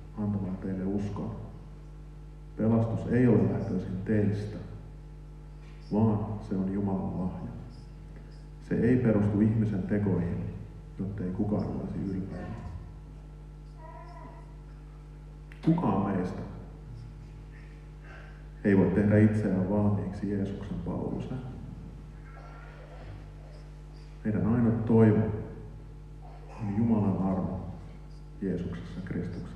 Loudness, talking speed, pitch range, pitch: -29 LUFS, 80 wpm, 95-150 Hz, 110 Hz